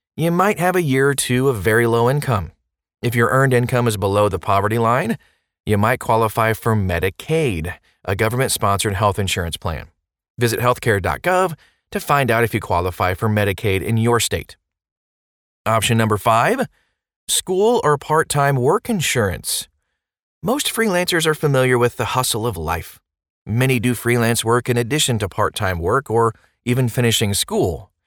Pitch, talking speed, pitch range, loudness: 115 Hz, 160 wpm, 100-130 Hz, -18 LUFS